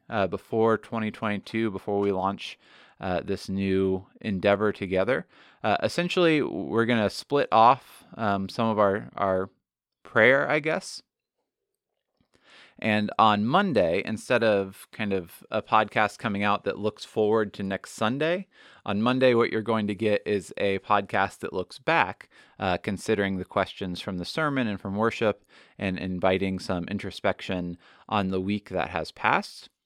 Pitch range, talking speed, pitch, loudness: 95-110 Hz, 155 wpm, 100 Hz, -26 LUFS